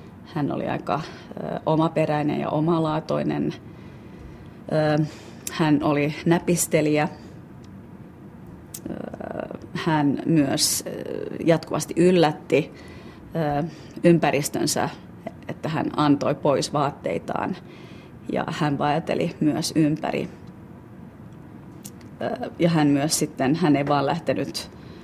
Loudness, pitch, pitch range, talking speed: -23 LUFS, 150 Hz, 145-160 Hz, 75 wpm